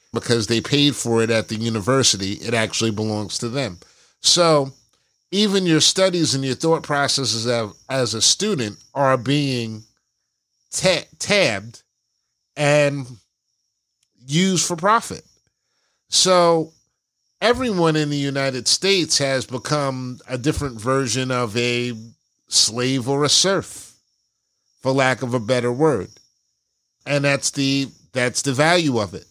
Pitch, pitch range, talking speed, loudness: 135 Hz, 120-150 Hz, 130 wpm, -19 LUFS